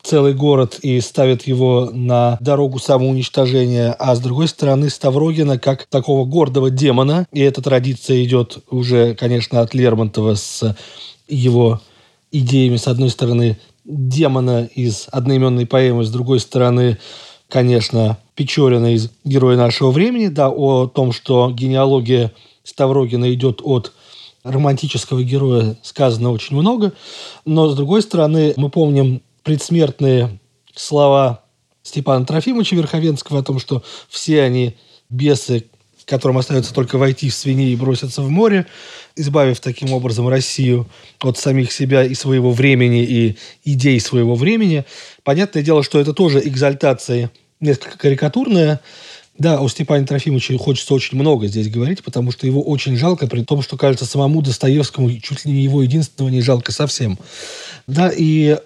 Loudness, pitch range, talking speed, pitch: -15 LUFS, 125-145 Hz, 140 wpm, 130 Hz